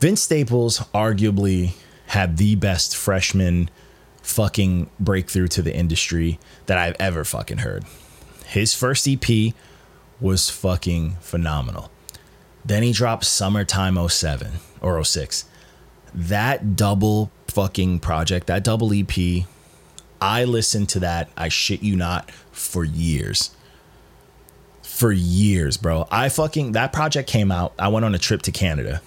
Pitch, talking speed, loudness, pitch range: 95 Hz, 130 wpm, -21 LUFS, 85-110 Hz